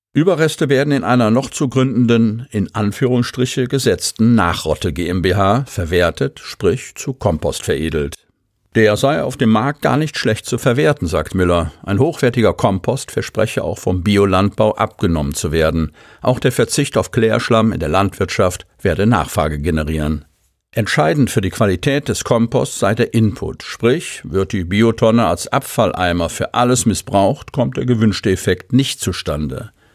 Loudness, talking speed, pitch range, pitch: -16 LUFS, 150 wpm, 90-125 Hz, 110 Hz